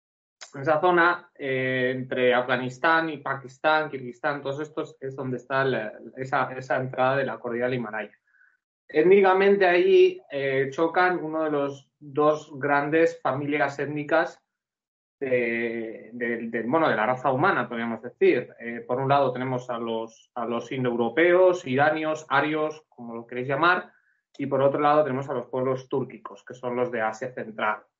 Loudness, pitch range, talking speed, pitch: -24 LUFS, 125-155 Hz, 160 wpm, 135 Hz